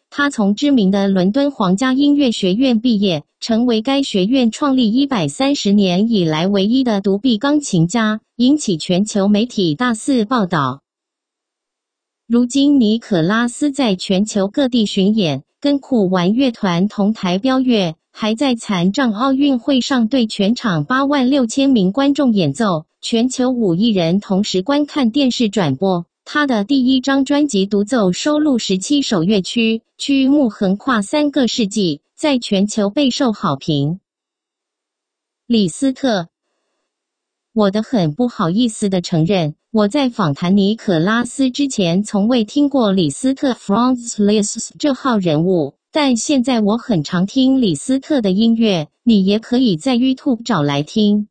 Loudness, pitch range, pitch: -16 LUFS, 195-270 Hz, 230 Hz